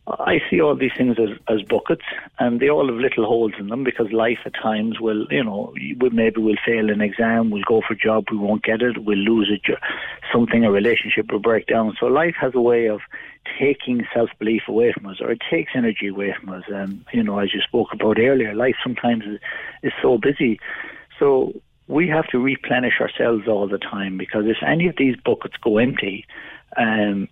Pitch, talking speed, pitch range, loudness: 110 Hz, 215 wpm, 105-125 Hz, -20 LUFS